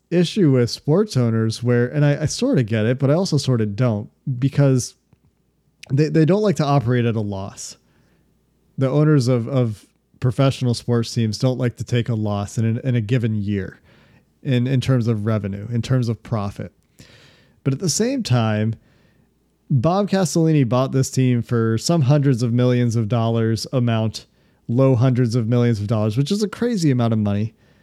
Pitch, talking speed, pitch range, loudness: 125 Hz, 190 wpm, 115-140 Hz, -20 LUFS